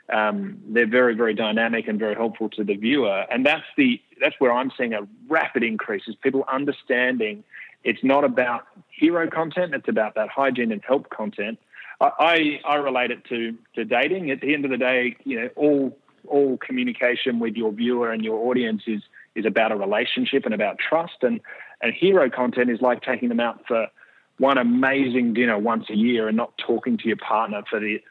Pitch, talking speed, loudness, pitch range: 125 Hz, 200 wpm, -22 LUFS, 115-140 Hz